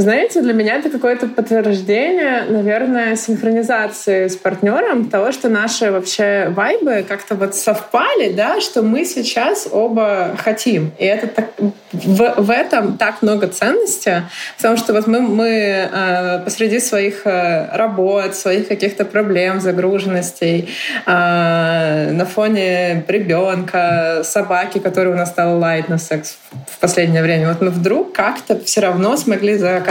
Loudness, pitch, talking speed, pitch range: -15 LUFS, 205 Hz, 135 wpm, 180-225 Hz